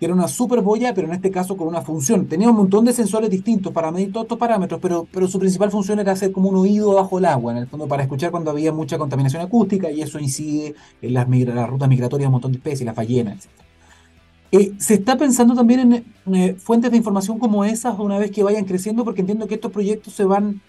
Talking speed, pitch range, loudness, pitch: 250 wpm, 150-215 Hz, -19 LUFS, 190 Hz